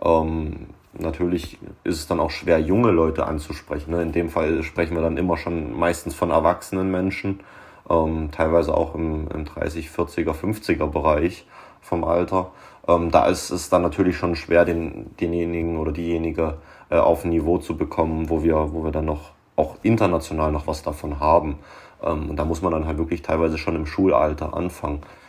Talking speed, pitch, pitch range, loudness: 180 wpm, 80 Hz, 80-85 Hz, -22 LUFS